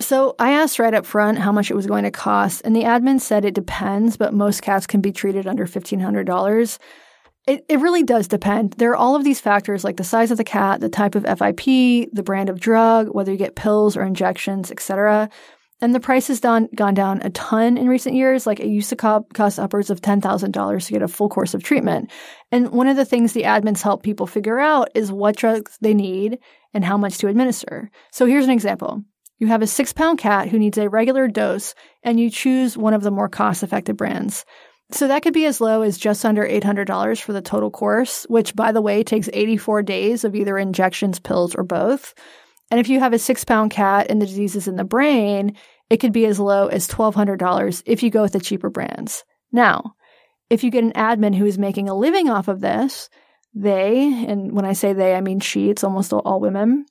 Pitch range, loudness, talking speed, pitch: 200-240 Hz, -18 LUFS, 225 wpm, 215 Hz